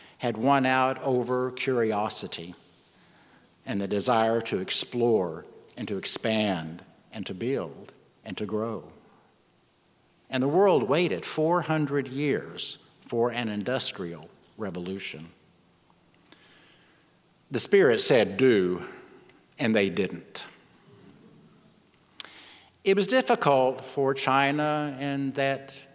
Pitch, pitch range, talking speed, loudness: 130 Hz, 115-150 Hz, 100 wpm, -26 LUFS